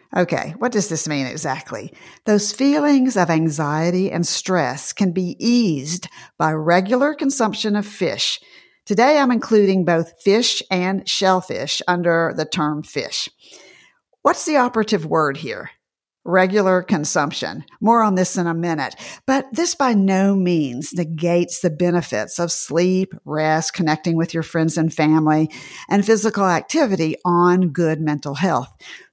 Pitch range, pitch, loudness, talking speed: 165-215 Hz, 180 Hz, -19 LUFS, 140 wpm